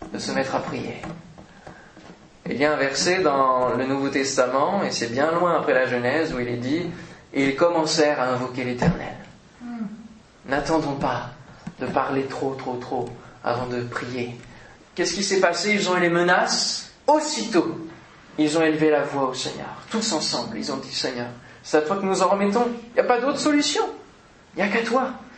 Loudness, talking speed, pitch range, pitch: -23 LUFS, 195 wpm, 130-195 Hz, 155 Hz